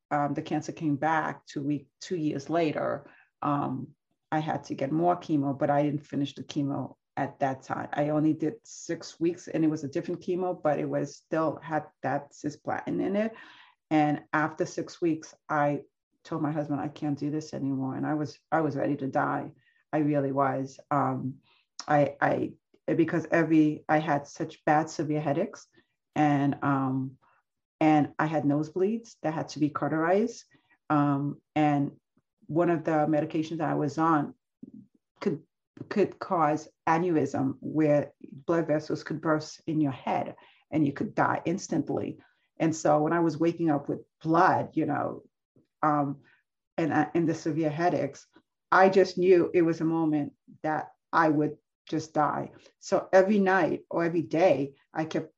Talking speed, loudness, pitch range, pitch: 170 wpm, -28 LUFS, 145-165 Hz, 155 Hz